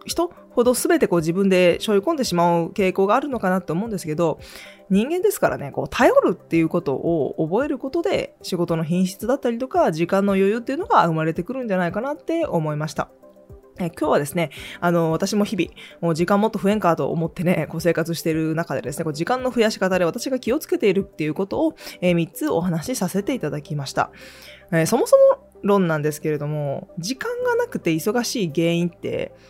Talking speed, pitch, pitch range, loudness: 425 characters per minute, 180 Hz, 165-235 Hz, -21 LUFS